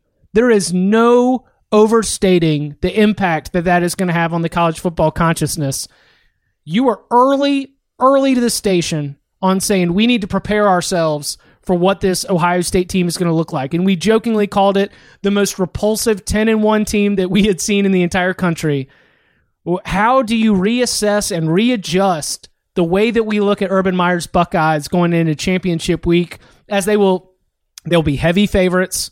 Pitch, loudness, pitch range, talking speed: 190 Hz, -15 LUFS, 170-210 Hz, 180 wpm